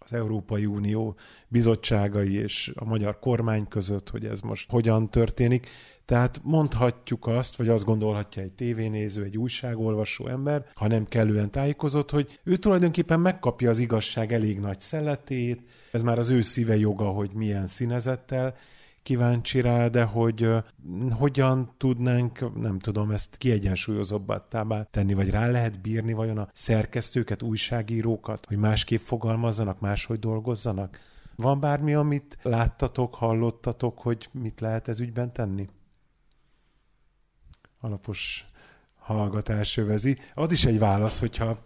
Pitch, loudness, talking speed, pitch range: 115 Hz, -26 LUFS, 130 wpm, 105-125 Hz